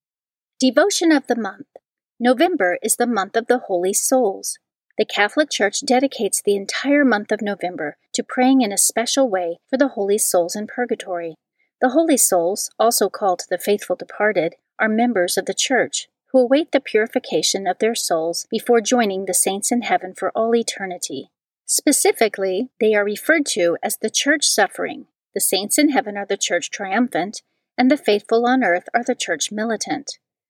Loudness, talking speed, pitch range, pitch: -19 LUFS, 175 wpm, 195-255 Hz, 220 Hz